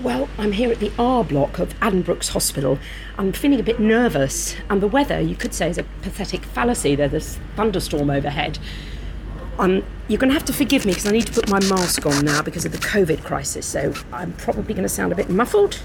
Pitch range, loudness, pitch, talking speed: 150-230 Hz, -20 LUFS, 195 Hz, 225 wpm